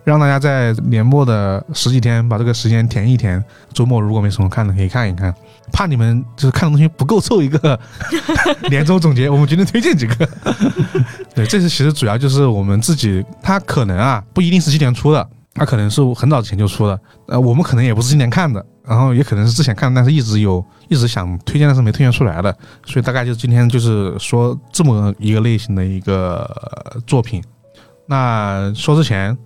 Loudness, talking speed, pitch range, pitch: -15 LUFS, 325 characters per minute, 110-145 Hz, 120 Hz